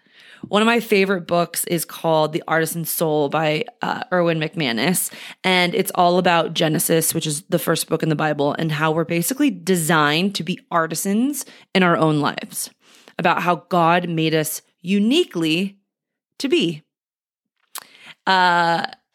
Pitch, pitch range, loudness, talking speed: 170 Hz, 160-190 Hz, -19 LUFS, 150 wpm